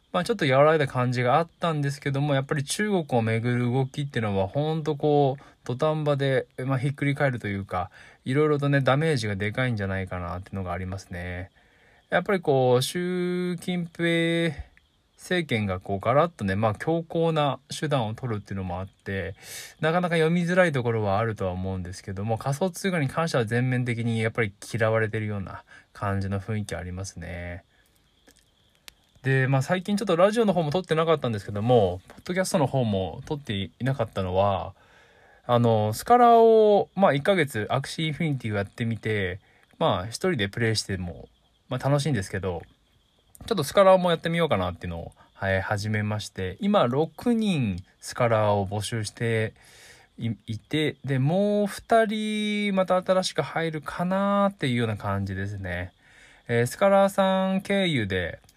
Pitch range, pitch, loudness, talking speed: 100-165 Hz, 125 Hz, -25 LUFS, 375 characters per minute